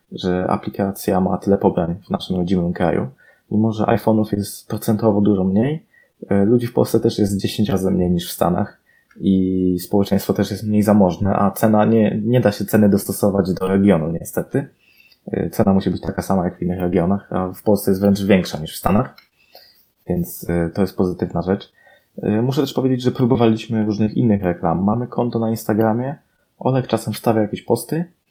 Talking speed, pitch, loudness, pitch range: 180 wpm, 100 Hz, -19 LUFS, 95-110 Hz